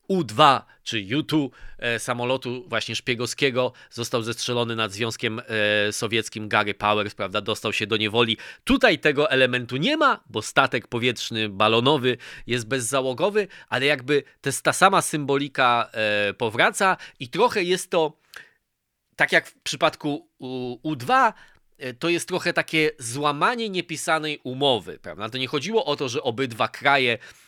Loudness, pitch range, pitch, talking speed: -23 LUFS, 115-150 Hz, 125 Hz, 145 wpm